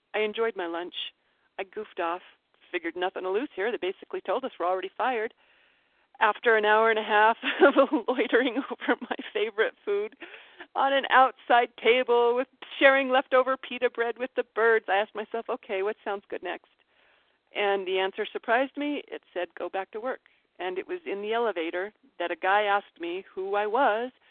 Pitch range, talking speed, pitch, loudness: 200-270 Hz, 190 wpm, 230 Hz, -27 LUFS